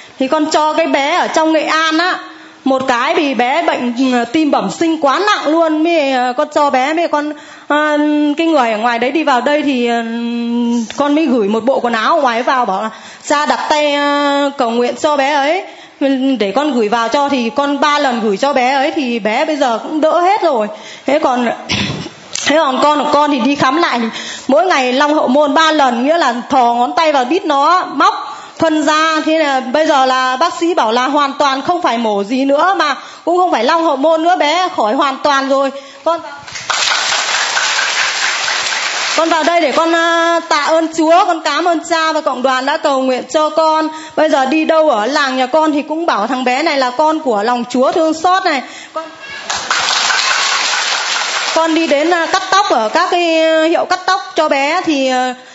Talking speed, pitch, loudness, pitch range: 210 wpm, 300 Hz, -13 LUFS, 265-325 Hz